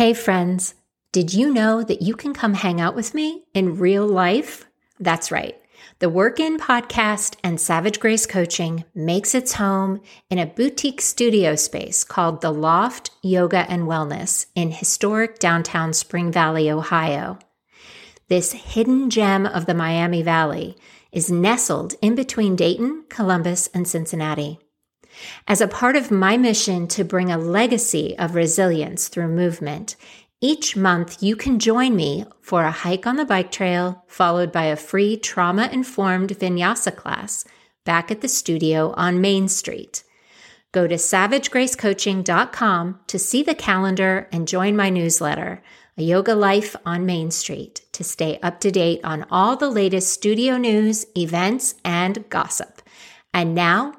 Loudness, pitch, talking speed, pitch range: -20 LUFS, 190 Hz, 150 wpm, 170-220 Hz